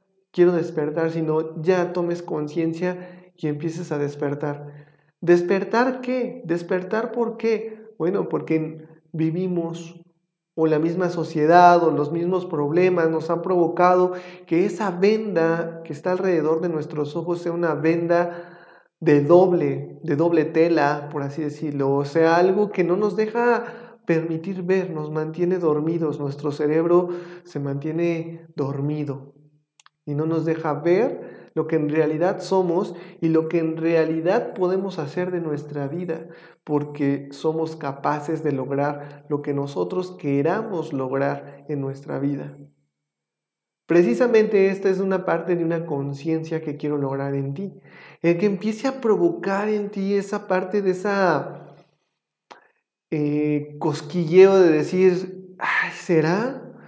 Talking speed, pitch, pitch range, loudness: 135 wpm, 165 Hz, 150-180 Hz, -22 LUFS